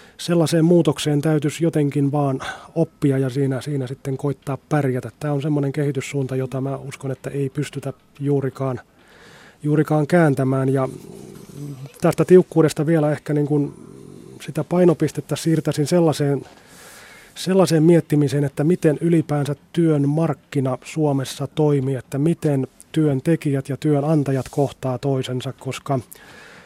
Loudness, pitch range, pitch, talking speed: -20 LUFS, 135-155 Hz, 145 Hz, 120 wpm